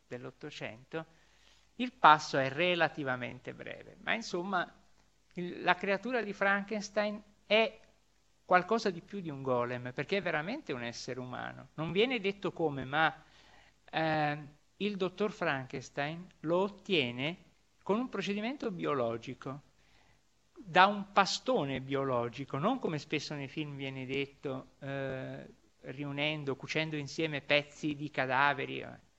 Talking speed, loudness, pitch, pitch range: 120 wpm, -33 LUFS, 155 Hz, 135-195 Hz